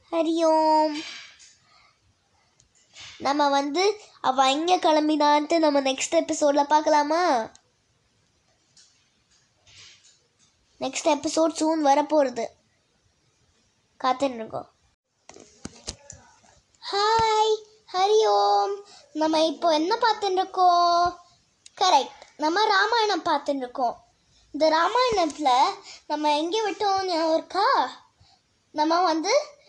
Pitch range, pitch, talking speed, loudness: 295-380 Hz, 320 Hz, 70 wpm, -23 LUFS